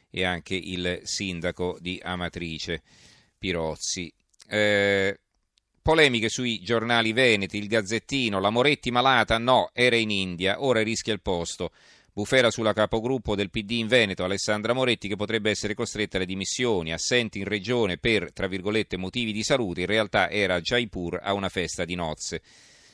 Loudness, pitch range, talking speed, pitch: -25 LUFS, 95-115 Hz, 155 wpm, 105 Hz